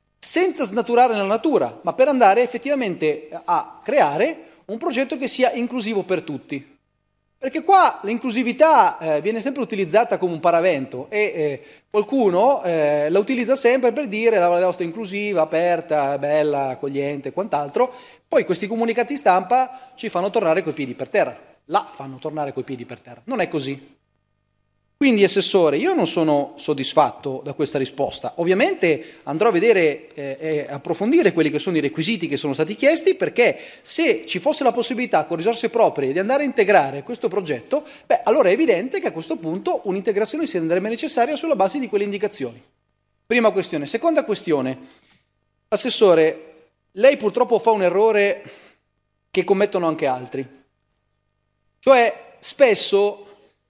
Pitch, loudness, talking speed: 195 Hz, -20 LUFS, 150 wpm